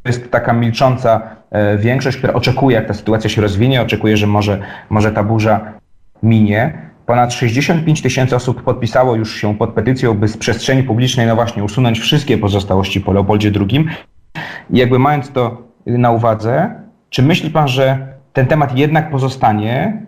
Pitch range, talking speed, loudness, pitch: 110-135 Hz, 160 wpm, -14 LUFS, 120 Hz